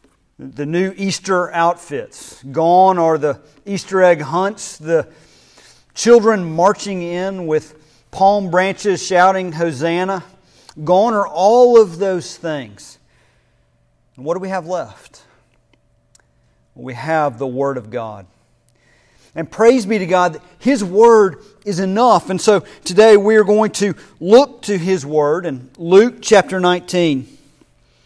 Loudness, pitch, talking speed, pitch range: -15 LUFS, 180 Hz, 130 wpm, 150-200 Hz